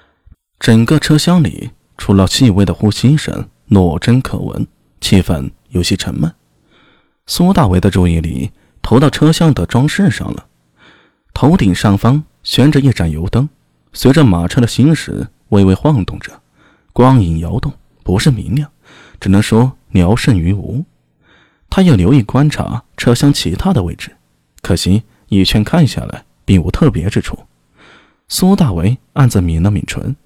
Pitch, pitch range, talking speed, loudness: 110 Hz, 90-140 Hz, 220 characters per minute, -13 LUFS